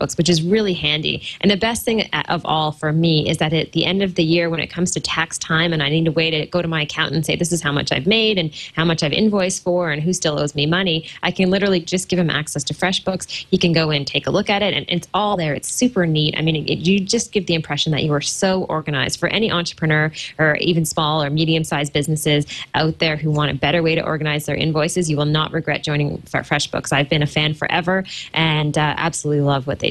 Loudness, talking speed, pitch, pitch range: -18 LUFS, 265 wpm, 160 Hz, 150-175 Hz